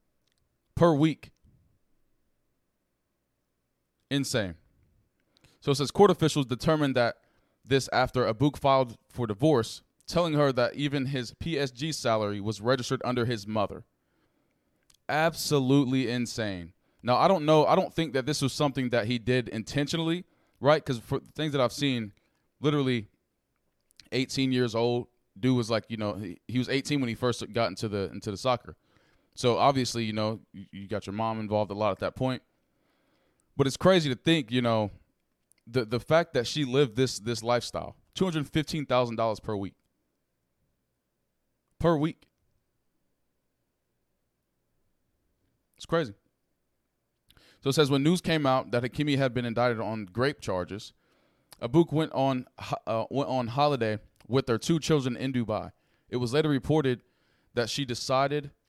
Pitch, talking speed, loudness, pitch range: 125 Hz, 155 wpm, -28 LUFS, 110-145 Hz